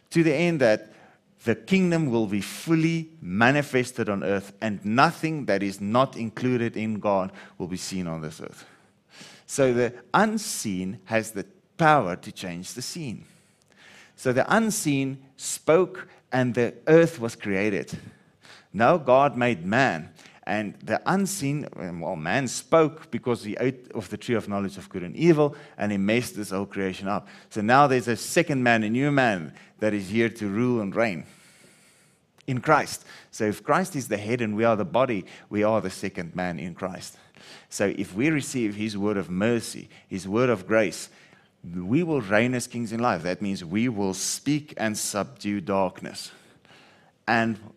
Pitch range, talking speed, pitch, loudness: 100-140 Hz, 175 wpm, 115 Hz, -25 LUFS